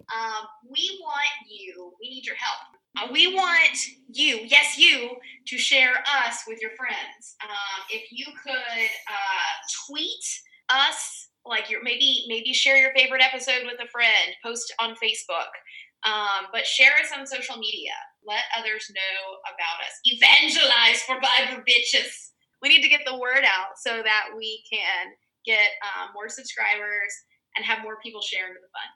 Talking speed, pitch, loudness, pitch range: 165 wpm, 240 Hz, -21 LUFS, 215-275 Hz